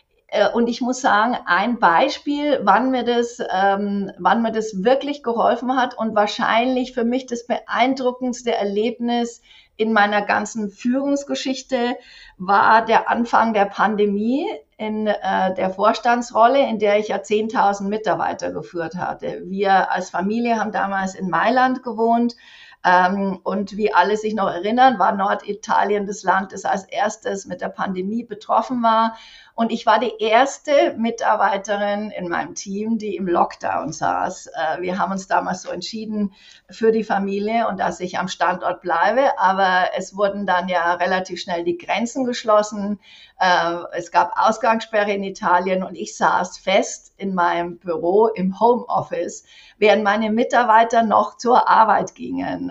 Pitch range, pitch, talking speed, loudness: 195-235 Hz, 210 Hz, 145 wpm, -20 LUFS